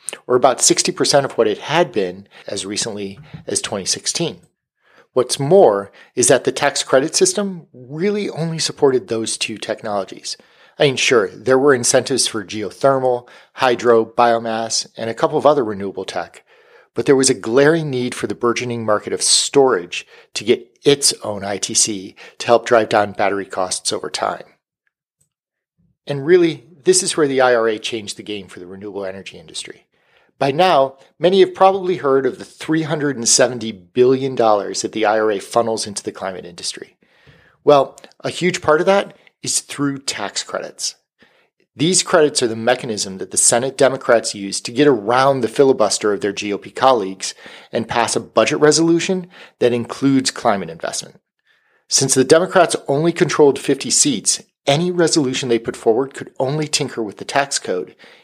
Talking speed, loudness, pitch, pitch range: 165 wpm, -17 LUFS, 130 Hz, 110-155 Hz